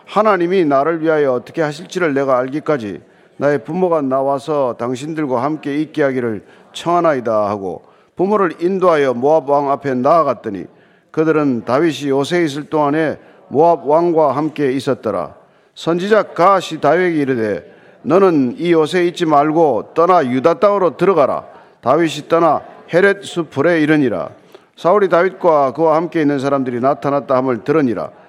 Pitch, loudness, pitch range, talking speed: 155 Hz, -15 LUFS, 140-170 Hz, 340 characters per minute